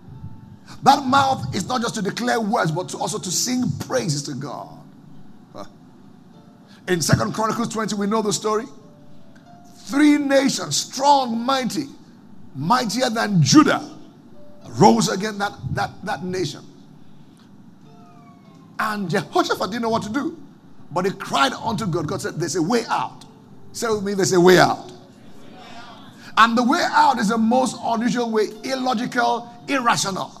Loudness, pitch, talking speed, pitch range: -20 LUFS, 225 Hz, 145 wpm, 200-245 Hz